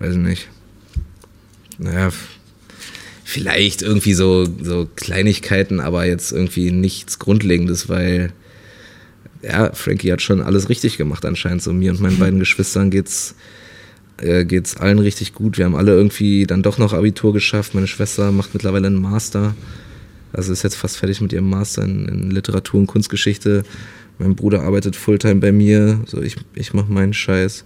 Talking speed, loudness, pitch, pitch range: 165 wpm, -17 LUFS, 100 Hz, 95-105 Hz